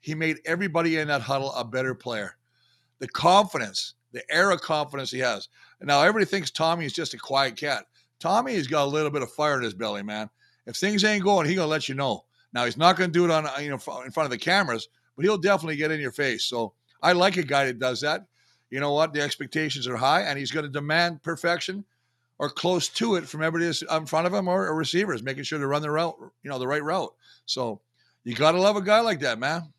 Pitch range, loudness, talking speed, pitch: 135-170 Hz, -25 LUFS, 245 wpm, 150 Hz